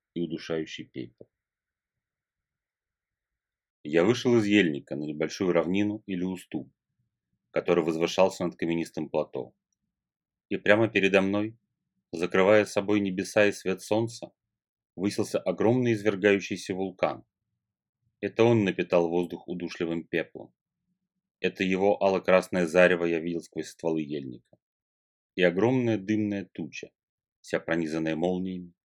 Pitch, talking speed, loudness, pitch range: 95 Hz, 110 wpm, -27 LUFS, 85-105 Hz